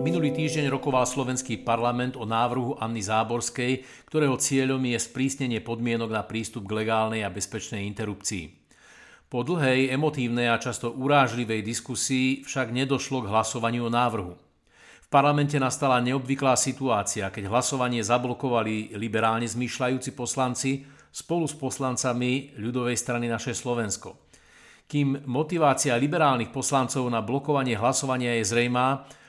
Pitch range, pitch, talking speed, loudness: 115-135 Hz, 125 Hz, 125 wpm, -26 LUFS